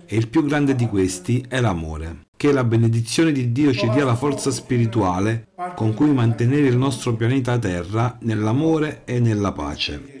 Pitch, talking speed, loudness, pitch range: 120 Hz, 170 wpm, -20 LUFS, 110-140 Hz